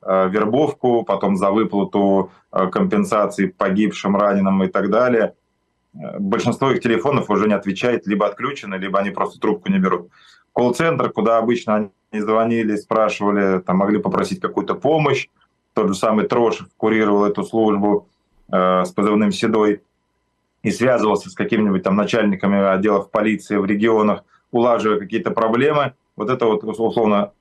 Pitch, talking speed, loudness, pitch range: 105 Hz, 135 wpm, -18 LUFS, 100-110 Hz